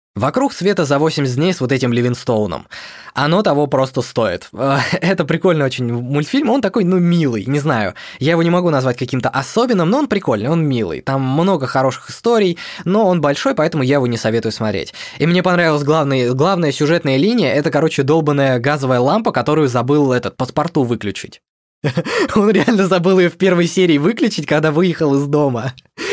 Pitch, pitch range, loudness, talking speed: 150 Hz, 130-180 Hz, -16 LUFS, 175 wpm